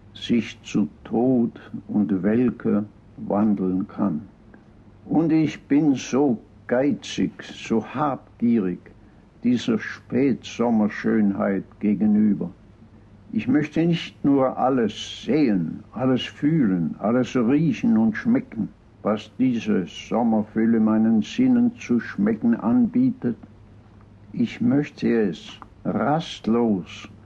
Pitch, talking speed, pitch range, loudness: 115 Hz, 90 wpm, 105-160 Hz, -23 LUFS